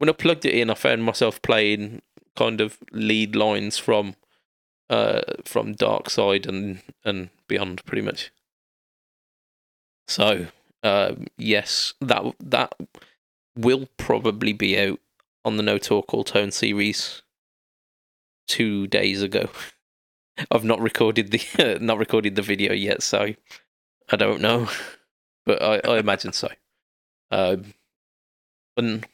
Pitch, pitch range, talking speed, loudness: 105 Hz, 100-115 Hz, 130 wpm, -22 LUFS